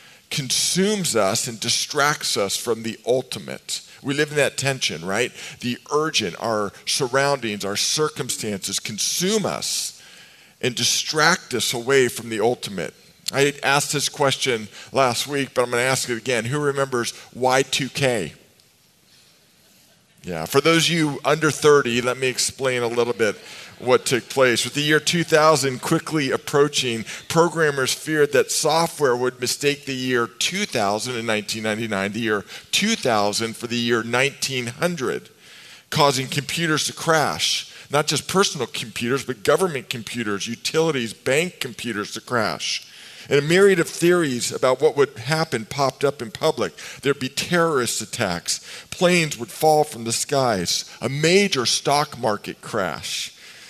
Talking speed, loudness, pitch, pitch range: 145 wpm, -21 LUFS, 135 Hz, 120-155 Hz